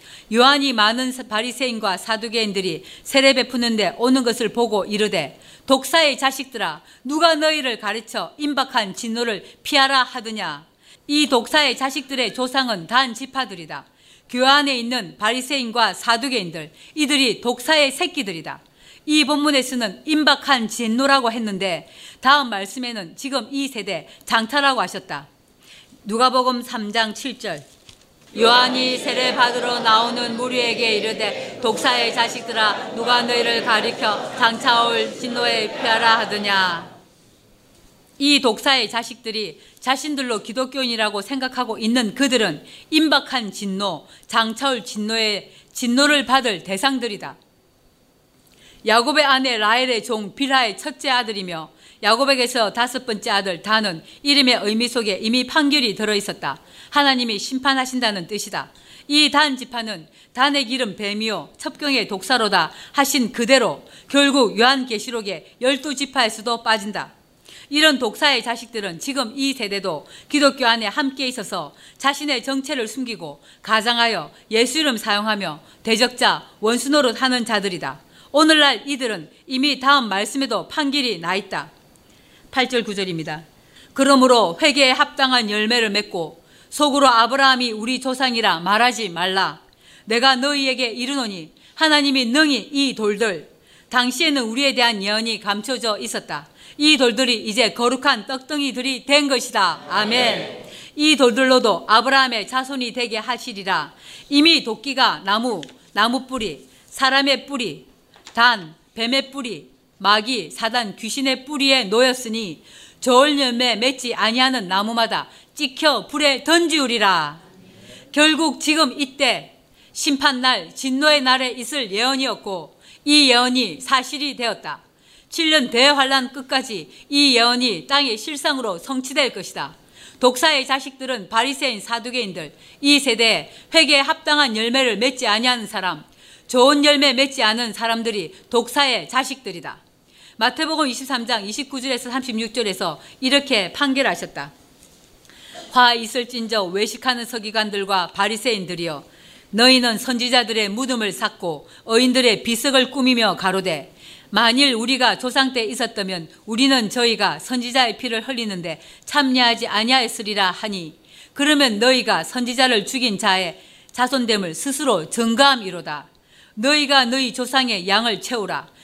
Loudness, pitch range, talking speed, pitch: -18 LUFS, 220-270 Hz, 300 characters per minute, 245 Hz